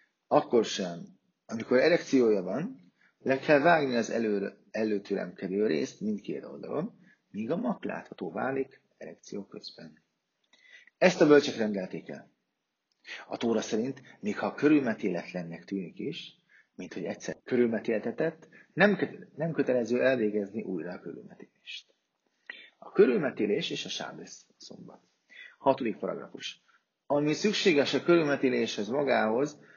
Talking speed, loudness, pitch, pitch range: 115 wpm, -29 LUFS, 130 Hz, 110-150 Hz